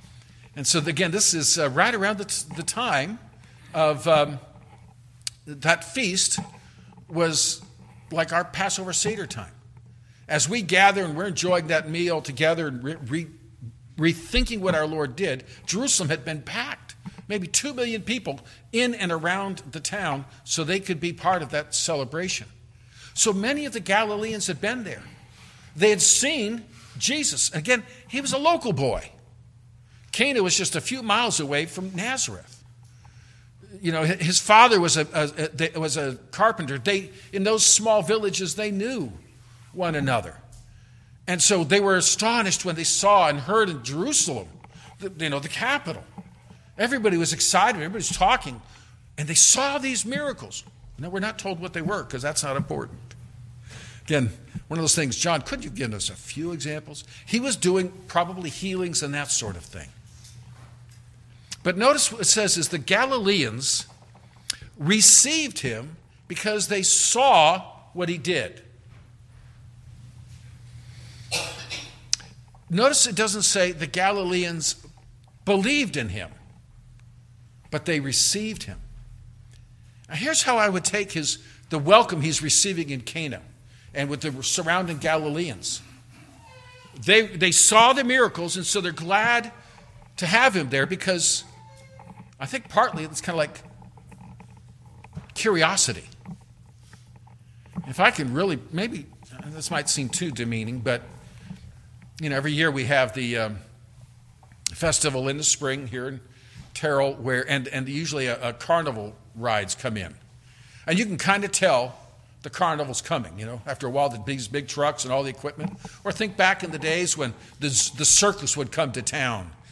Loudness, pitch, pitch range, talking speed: -22 LUFS, 155 Hz, 120-185 Hz, 155 wpm